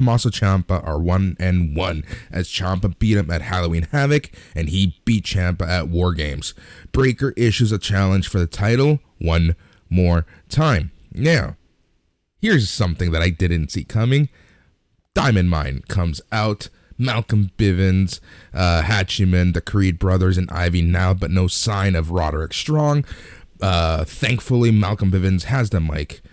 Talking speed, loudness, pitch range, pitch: 145 wpm, -19 LUFS, 85-110 Hz, 95 Hz